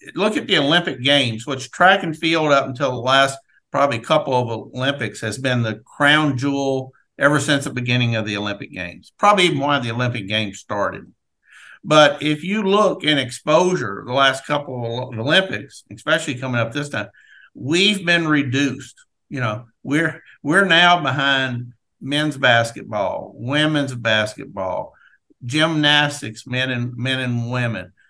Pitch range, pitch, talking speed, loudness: 120-150 Hz, 135 Hz, 155 wpm, -18 LUFS